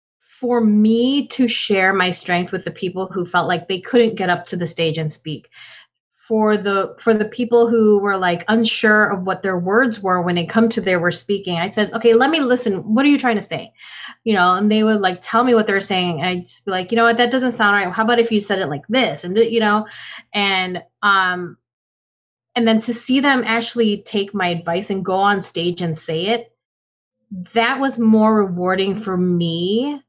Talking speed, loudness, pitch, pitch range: 225 wpm, -17 LUFS, 205 Hz, 180-230 Hz